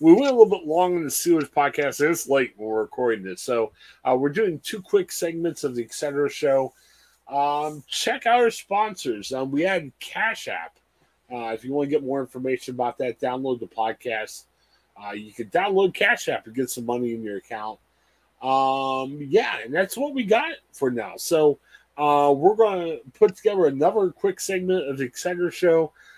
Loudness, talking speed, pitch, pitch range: -23 LUFS, 195 wpm, 145 Hz, 125-190 Hz